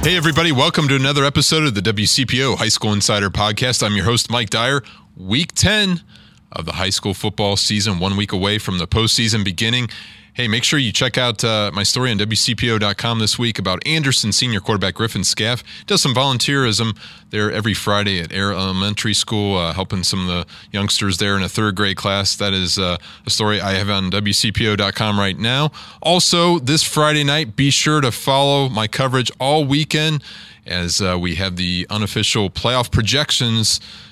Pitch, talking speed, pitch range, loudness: 110 Hz, 185 wpm, 100-130 Hz, -17 LUFS